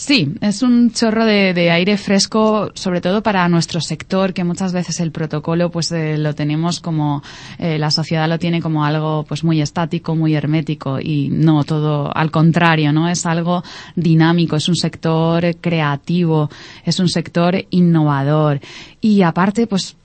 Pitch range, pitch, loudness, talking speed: 155-175 Hz, 165 Hz, -16 LUFS, 165 wpm